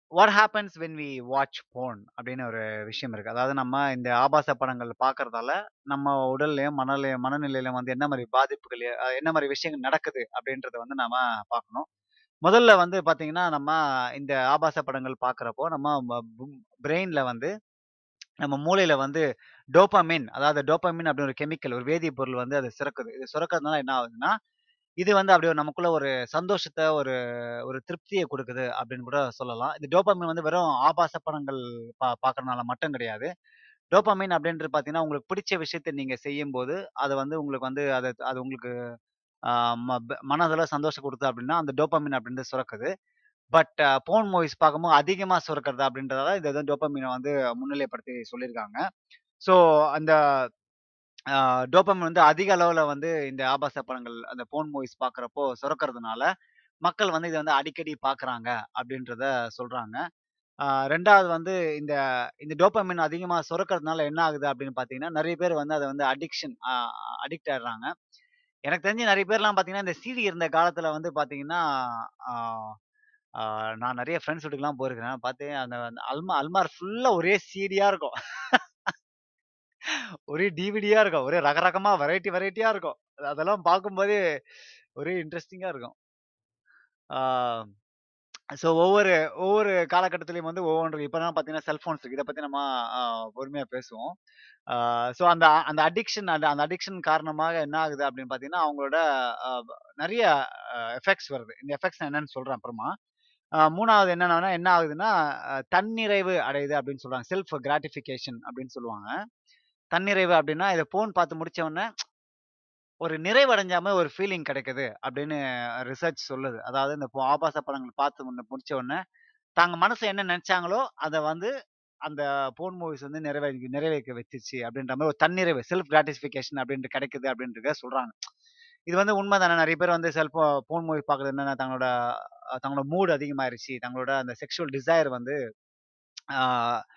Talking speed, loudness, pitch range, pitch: 135 wpm, -26 LUFS, 130-175 Hz, 150 Hz